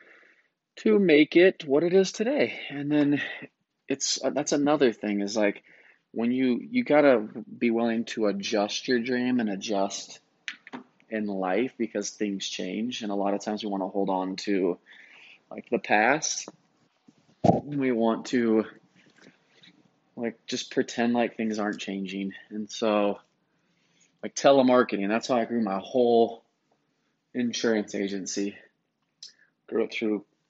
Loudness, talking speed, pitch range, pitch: -26 LUFS, 140 wpm, 100-125 Hz, 115 Hz